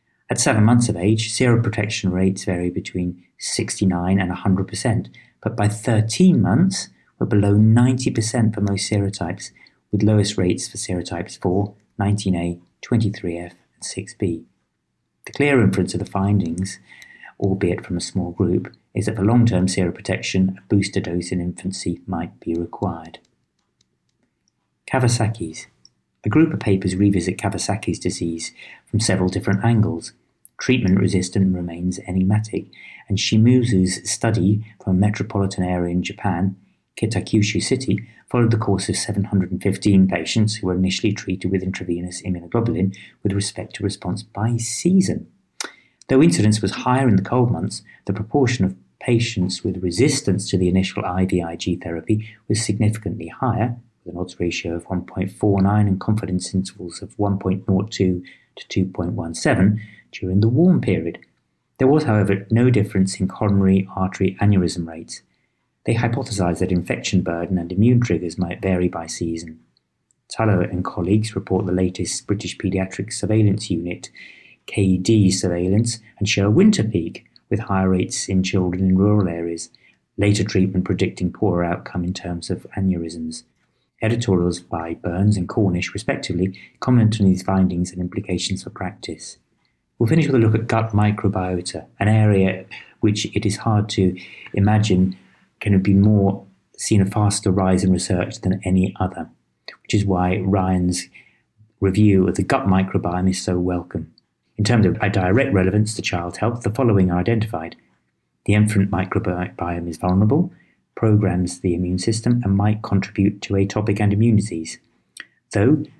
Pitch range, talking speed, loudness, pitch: 90-110 Hz, 145 wpm, -20 LUFS, 95 Hz